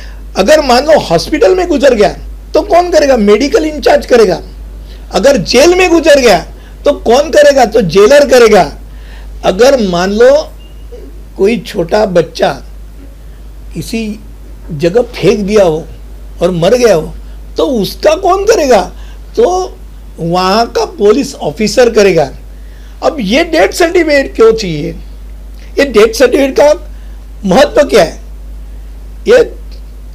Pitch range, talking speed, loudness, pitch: 195-315 Hz, 125 wpm, -8 LUFS, 245 Hz